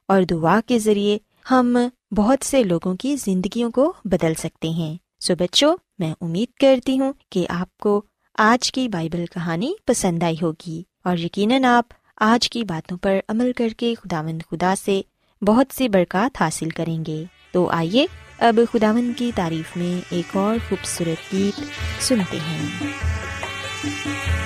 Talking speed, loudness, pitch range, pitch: 150 wpm, -21 LUFS, 165-235 Hz, 190 Hz